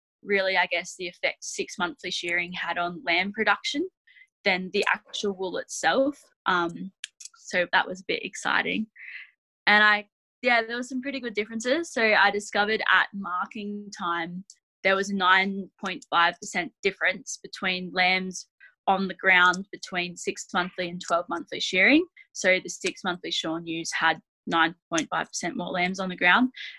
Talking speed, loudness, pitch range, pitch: 155 wpm, -25 LUFS, 180-220 Hz, 190 Hz